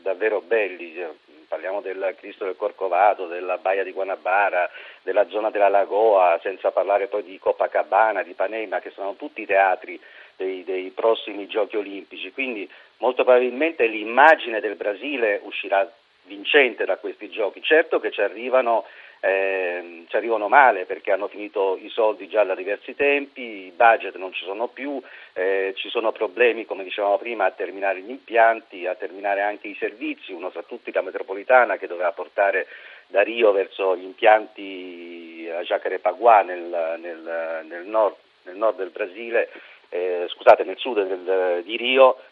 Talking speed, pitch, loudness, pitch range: 155 wpm, 100 Hz, -22 LUFS, 95-135 Hz